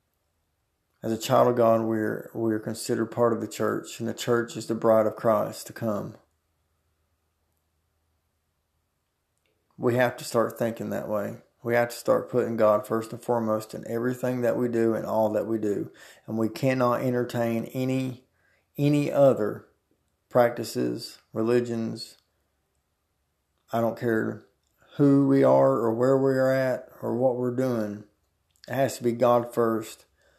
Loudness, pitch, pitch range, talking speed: -26 LUFS, 115 Hz, 85-120 Hz, 155 wpm